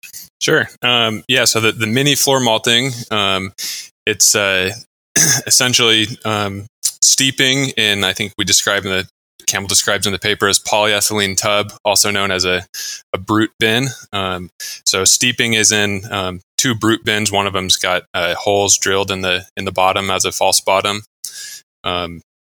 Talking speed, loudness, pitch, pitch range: 165 wpm, -14 LUFS, 105 Hz, 95-115 Hz